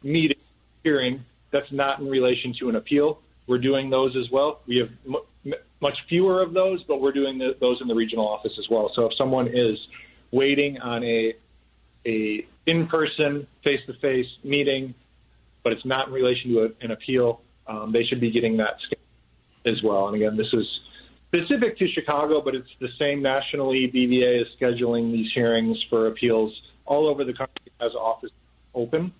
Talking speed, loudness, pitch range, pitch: 175 wpm, -24 LUFS, 115-140 Hz, 125 Hz